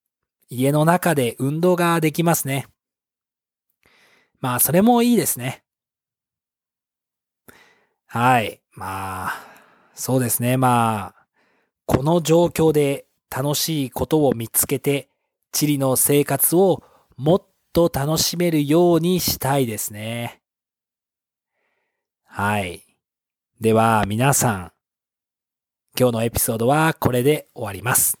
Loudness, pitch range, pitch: -19 LUFS, 120-160 Hz, 135 Hz